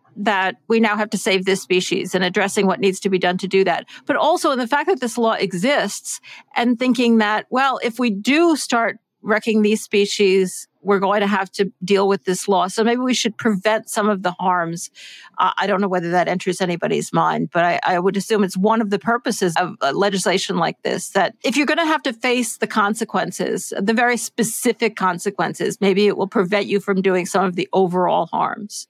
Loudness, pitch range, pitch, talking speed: -19 LUFS, 190-230 Hz, 205 Hz, 220 wpm